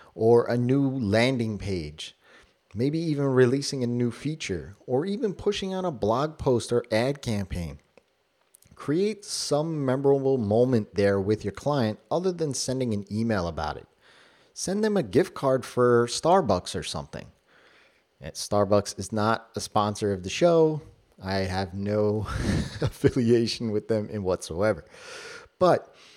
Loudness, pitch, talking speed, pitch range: -26 LUFS, 120 Hz, 140 wpm, 105-140 Hz